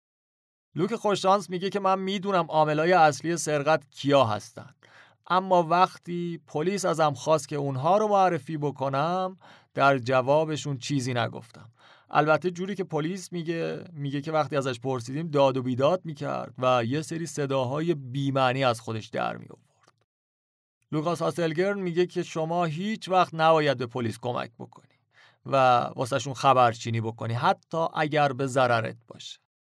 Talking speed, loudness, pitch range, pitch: 140 wpm, -26 LUFS, 135-175 Hz, 150 Hz